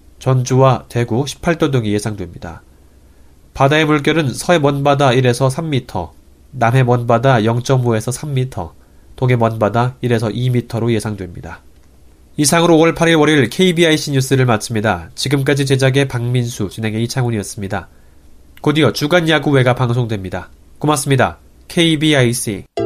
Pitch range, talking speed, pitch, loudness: 95-140 Hz, 305 characters per minute, 120 Hz, -15 LUFS